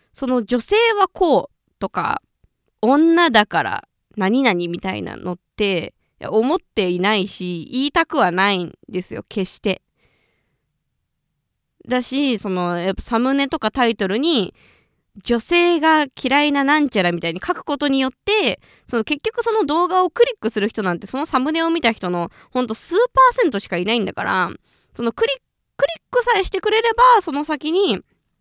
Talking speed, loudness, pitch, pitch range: 315 characters per minute, -19 LUFS, 265 Hz, 205-345 Hz